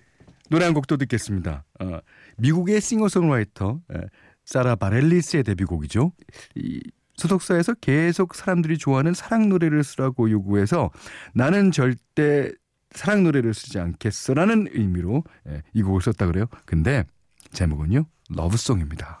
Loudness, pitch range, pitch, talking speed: -22 LUFS, 100-165 Hz, 130 Hz, 305 characters per minute